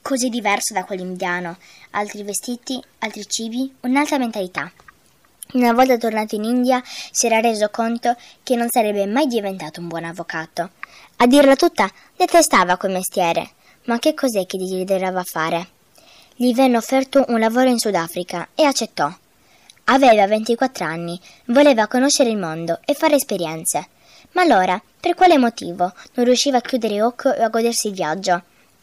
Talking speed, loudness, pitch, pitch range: 150 wpm, -18 LUFS, 225 Hz, 185-255 Hz